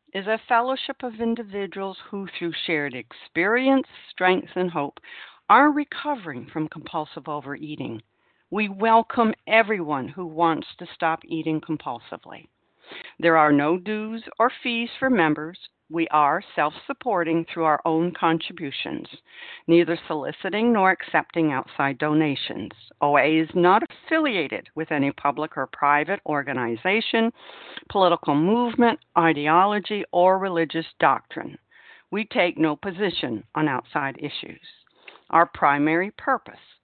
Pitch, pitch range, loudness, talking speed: 170 Hz, 155-215 Hz, -23 LUFS, 120 wpm